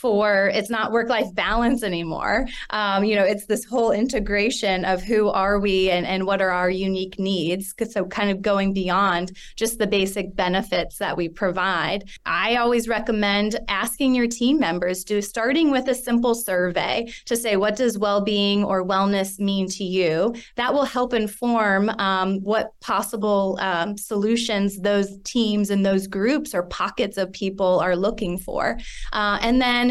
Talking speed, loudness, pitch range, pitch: 170 wpm, -22 LUFS, 190-230 Hz, 205 Hz